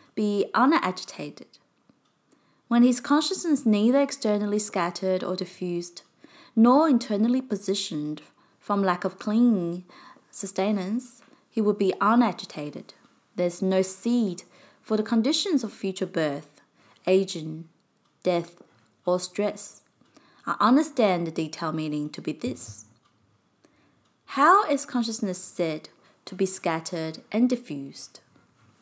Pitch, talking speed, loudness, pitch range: 195 Hz, 110 wpm, -25 LUFS, 175-235 Hz